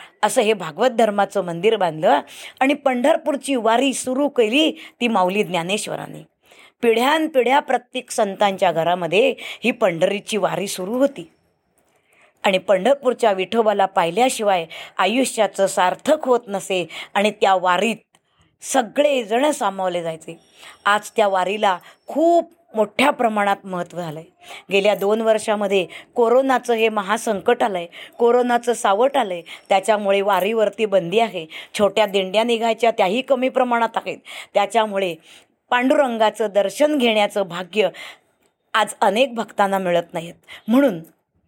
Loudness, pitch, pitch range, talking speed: -19 LUFS, 215 Hz, 195-245 Hz, 115 wpm